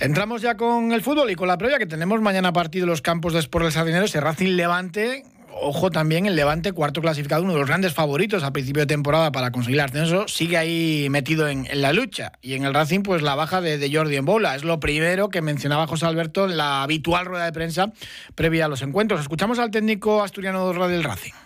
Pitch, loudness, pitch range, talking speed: 165 Hz, -21 LUFS, 150-195 Hz, 230 wpm